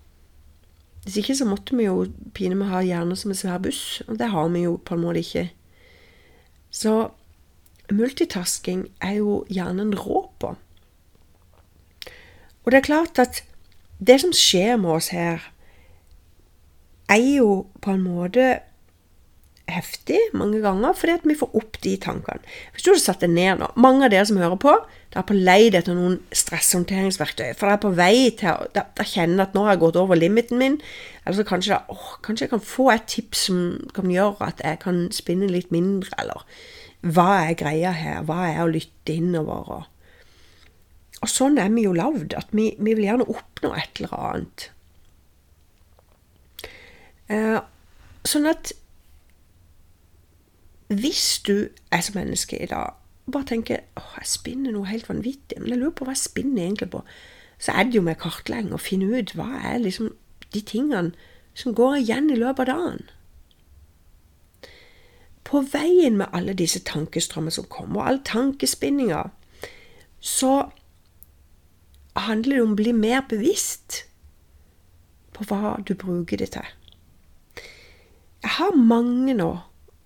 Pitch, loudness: 185 Hz, -22 LUFS